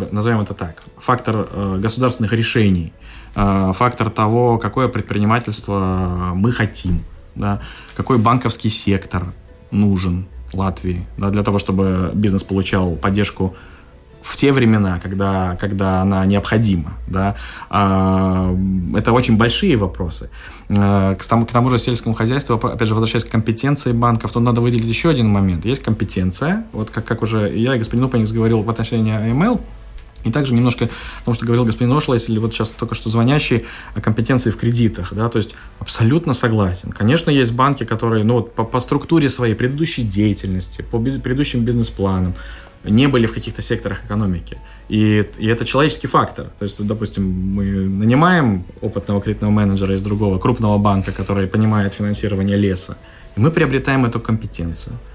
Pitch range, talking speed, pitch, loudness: 95-120 Hz, 155 wpm, 110 Hz, -18 LUFS